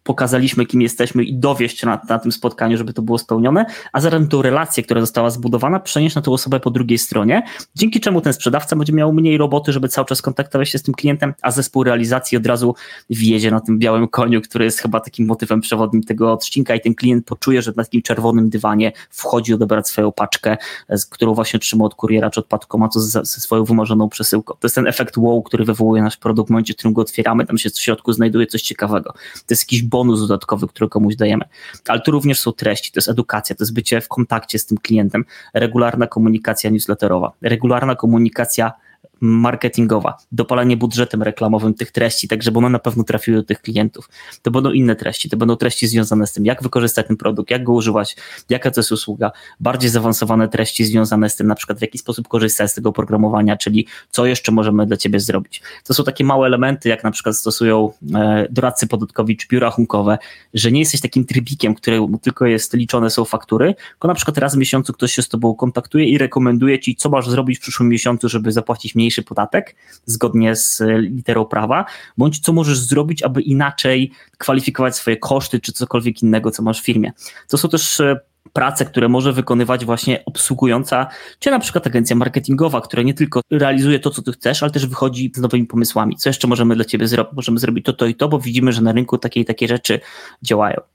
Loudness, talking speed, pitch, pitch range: -16 LUFS, 210 wpm, 120 Hz, 110-130 Hz